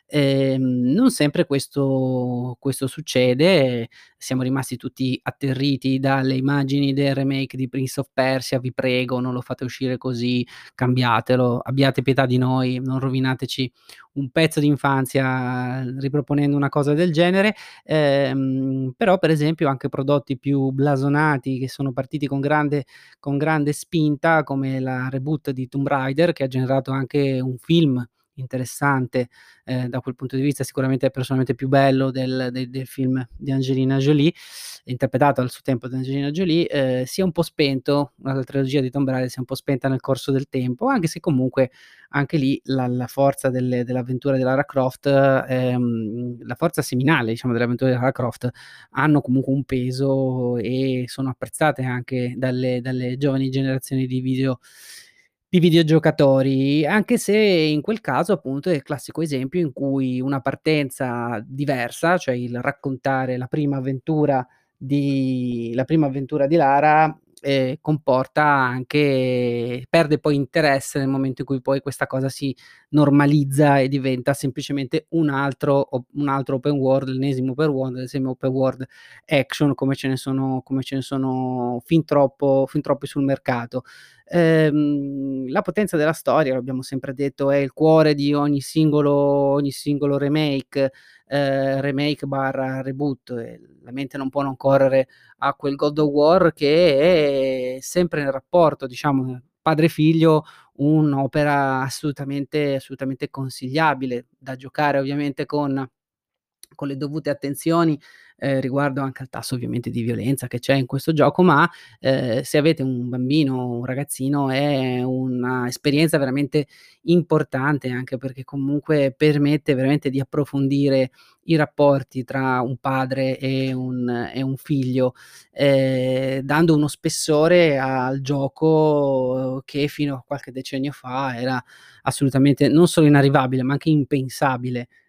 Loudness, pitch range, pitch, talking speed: -21 LUFS, 130-145 Hz, 135 Hz, 150 wpm